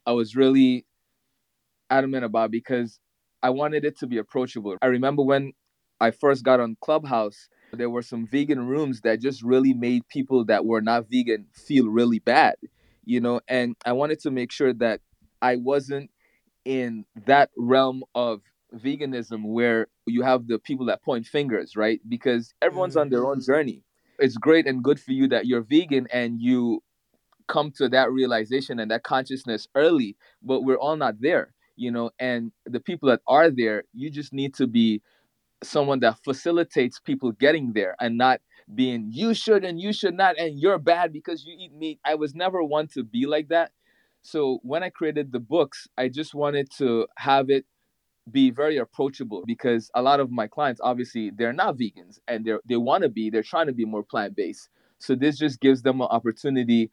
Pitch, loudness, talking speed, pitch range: 130 Hz, -24 LUFS, 190 wpm, 115-145 Hz